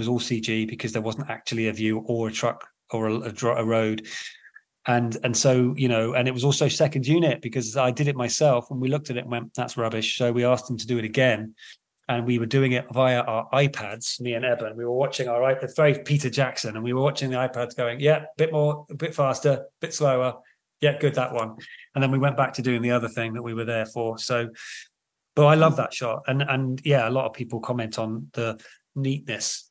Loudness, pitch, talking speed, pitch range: -24 LUFS, 125 Hz, 245 wpm, 115-135 Hz